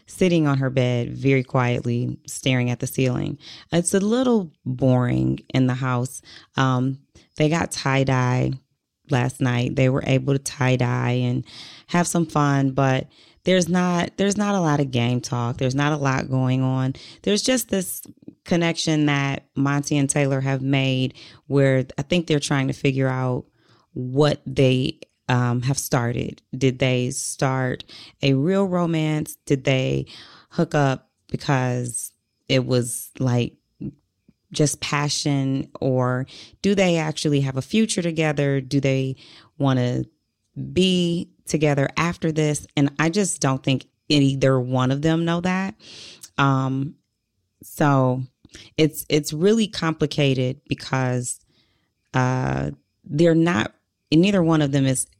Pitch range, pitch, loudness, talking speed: 125-155 Hz, 135 Hz, -22 LUFS, 140 wpm